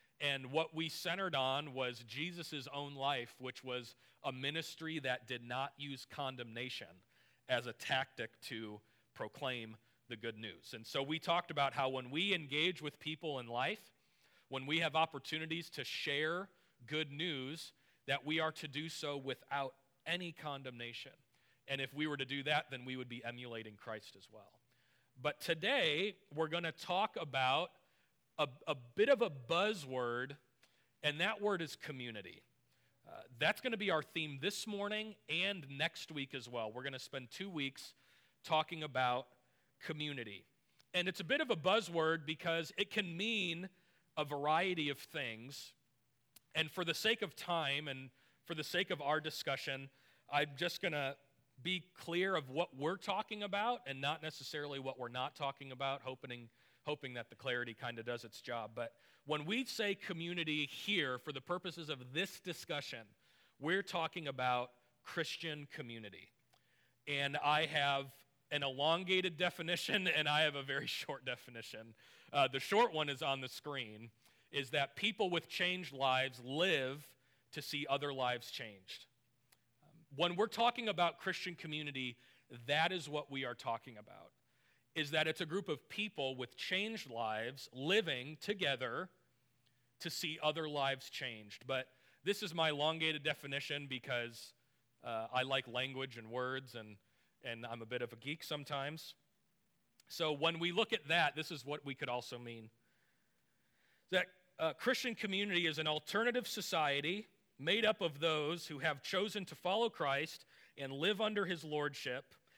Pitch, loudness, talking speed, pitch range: 145 Hz, -39 LUFS, 165 wpm, 130-170 Hz